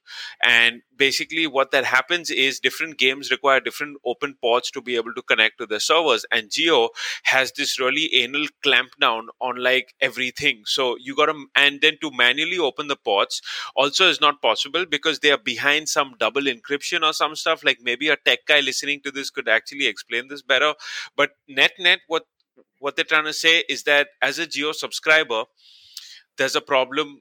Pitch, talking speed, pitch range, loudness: 145 Hz, 190 wpm, 130-155 Hz, -20 LUFS